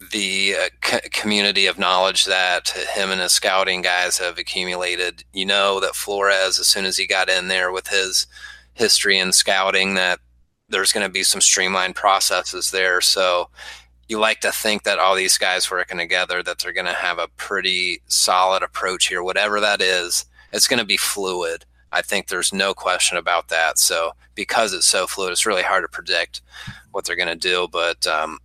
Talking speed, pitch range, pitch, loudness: 195 wpm, 90-95 Hz, 95 Hz, -18 LUFS